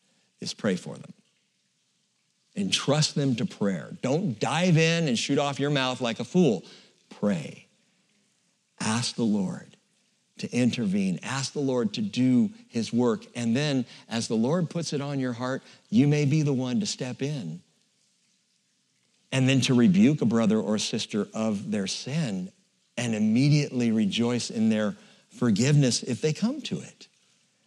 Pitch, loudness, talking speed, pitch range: 145 Hz, -26 LUFS, 155 wpm, 125-195 Hz